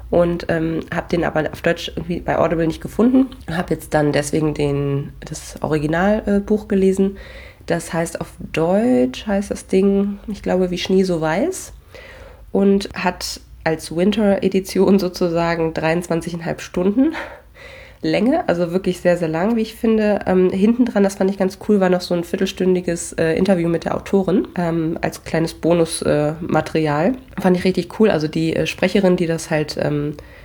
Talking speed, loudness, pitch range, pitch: 170 wpm, -19 LUFS, 165-200 Hz, 185 Hz